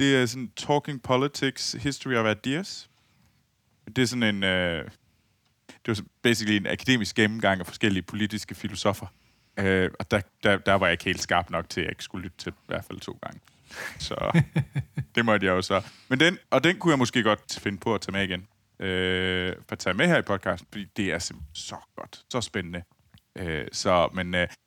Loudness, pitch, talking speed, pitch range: -26 LUFS, 105 Hz, 210 wpm, 95-130 Hz